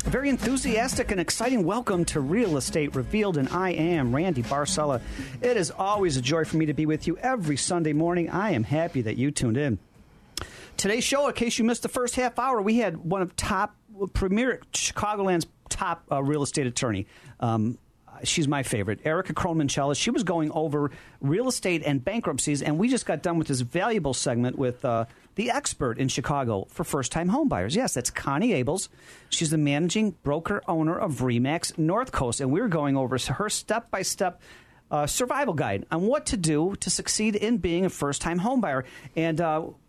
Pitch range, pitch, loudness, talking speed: 140-195 Hz, 160 Hz, -26 LUFS, 195 wpm